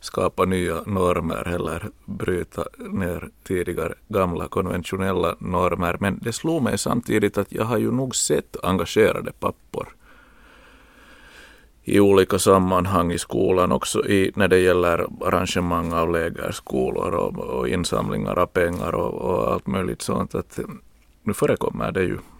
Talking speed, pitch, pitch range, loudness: 135 wpm, 95 Hz, 85-105 Hz, -22 LUFS